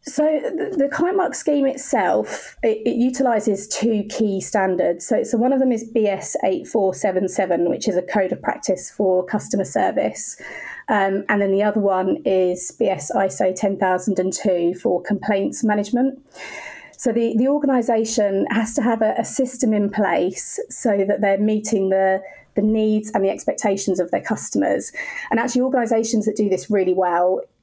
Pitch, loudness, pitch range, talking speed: 210 Hz, -19 LUFS, 195-245 Hz, 160 wpm